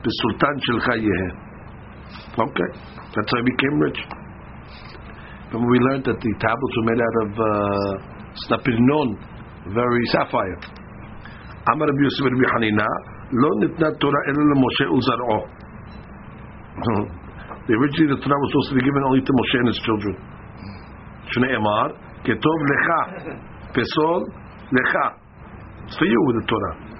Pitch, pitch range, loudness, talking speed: 115 Hz, 105-130 Hz, -20 LUFS, 140 wpm